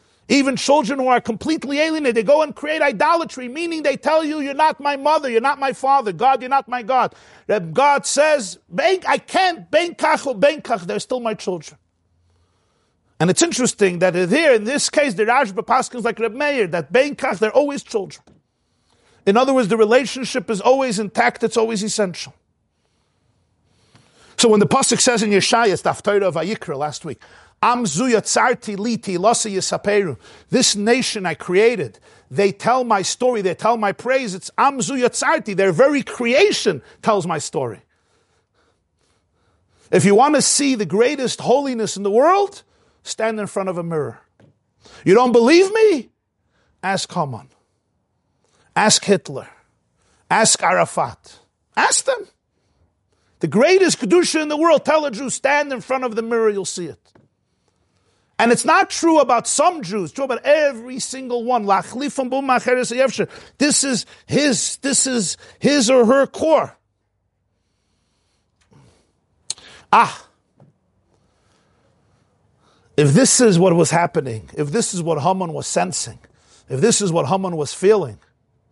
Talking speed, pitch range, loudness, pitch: 145 wpm, 185-275 Hz, -17 LUFS, 235 Hz